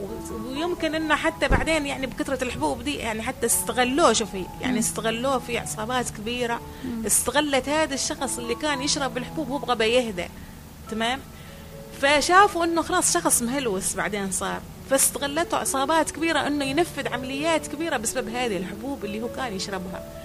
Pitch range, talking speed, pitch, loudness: 225-300 Hz, 145 wpm, 265 Hz, -24 LUFS